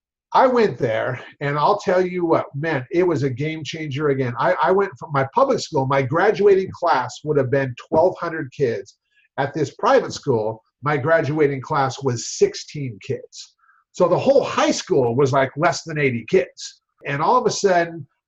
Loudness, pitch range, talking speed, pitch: -20 LUFS, 140-200 Hz, 185 wpm, 160 Hz